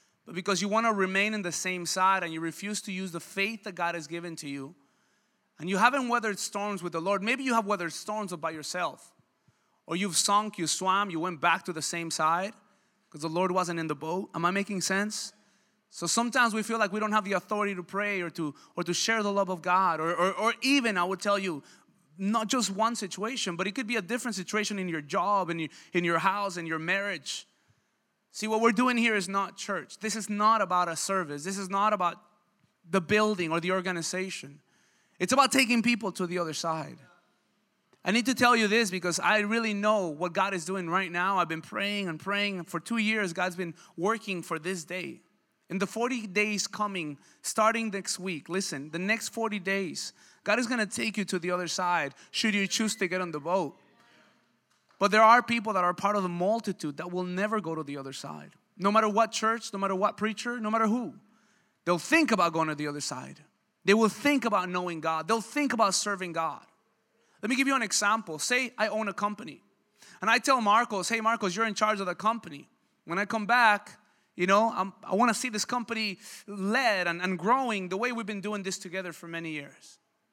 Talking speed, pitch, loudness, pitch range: 225 wpm, 195 Hz, -28 LUFS, 175-220 Hz